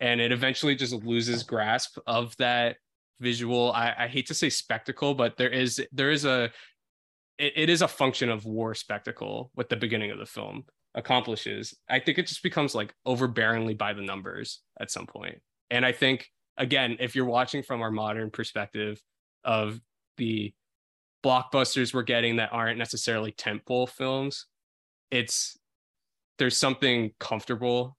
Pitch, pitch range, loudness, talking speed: 120 Hz, 115-130 Hz, -27 LUFS, 160 wpm